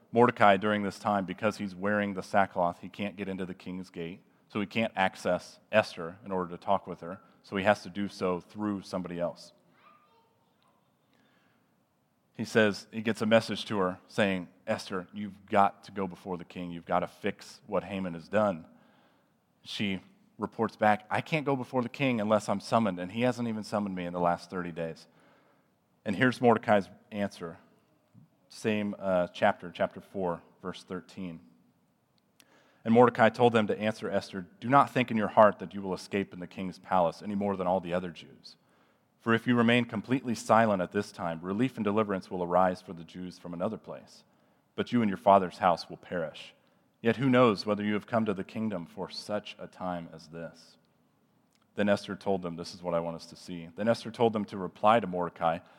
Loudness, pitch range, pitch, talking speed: -30 LUFS, 90-110 Hz, 100 Hz, 200 wpm